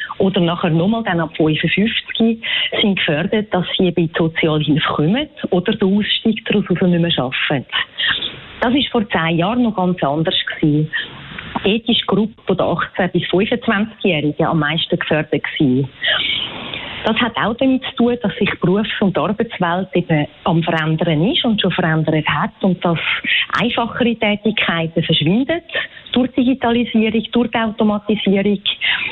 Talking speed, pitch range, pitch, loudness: 145 wpm, 165-225 Hz, 195 Hz, -17 LUFS